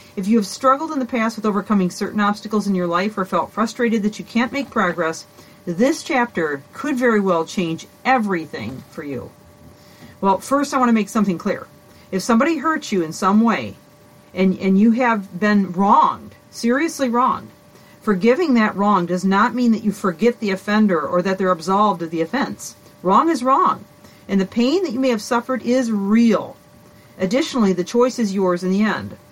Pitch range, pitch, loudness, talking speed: 190-245 Hz, 210 Hz, -19 LUFS, 190 wpm